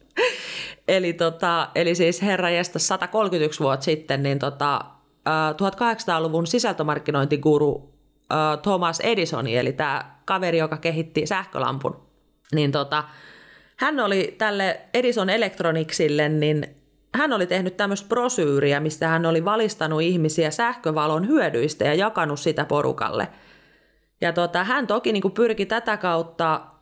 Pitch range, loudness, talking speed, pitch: 150-200 Hz, -23 LUFS, 120 wpm, 165 Hz